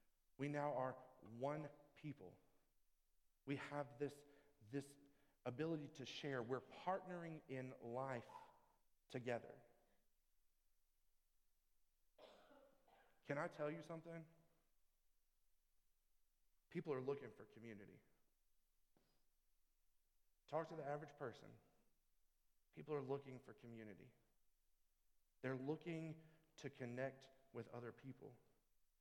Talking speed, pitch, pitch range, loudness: 90 wpm, 140 Hz, 130-155 Hz, -51 LUFS